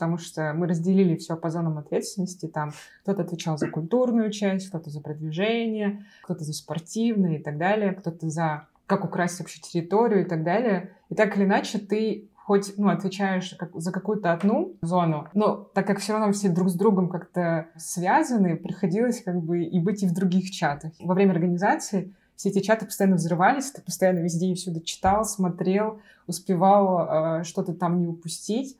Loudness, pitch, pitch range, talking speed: -25 LUFS, 185 Hz, 170-205 Hz, 175 wpm